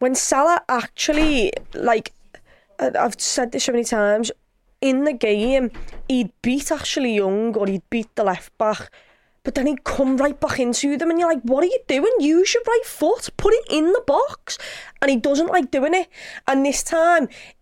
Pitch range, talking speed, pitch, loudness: 240-330 Hz, 190 wpm, 275 Hz, -20 LUFS